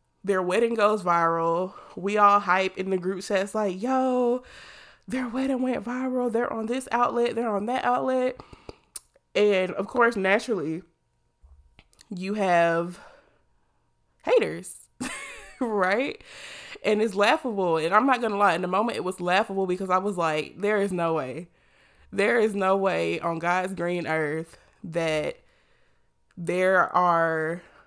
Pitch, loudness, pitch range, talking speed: 195 Hz, -25 LUFS, 175-235 Hz, 145 wpm